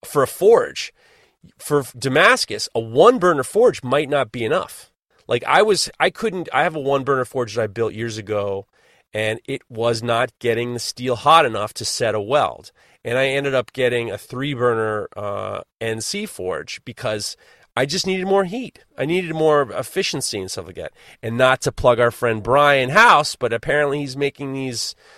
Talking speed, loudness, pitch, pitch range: 190 wpm, -19 LUFS, 130 Hz, 115-150 Hz